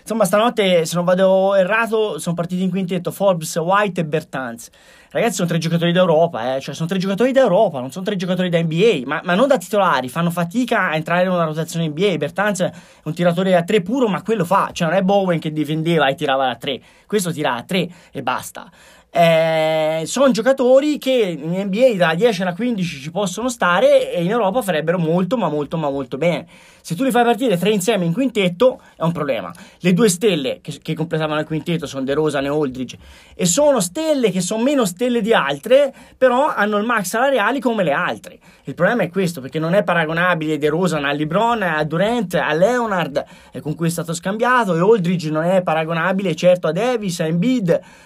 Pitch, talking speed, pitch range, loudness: 180 Hz, 205 wpm, 160-225 Hz, -18 LUFS